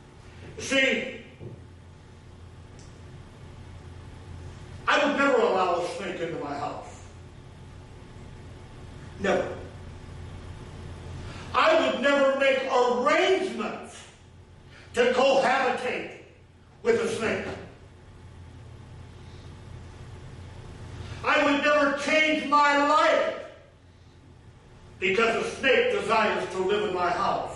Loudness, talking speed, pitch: -24 LUFS, 80 wpm, 175 Hz